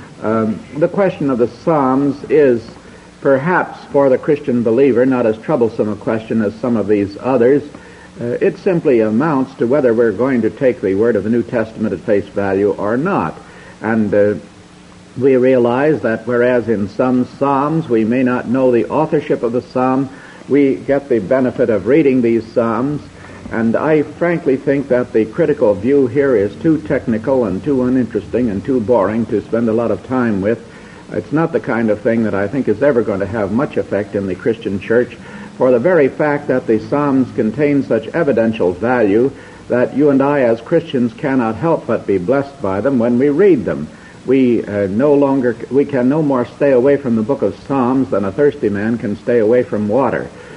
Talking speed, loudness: 195 wpm, -15 LUFS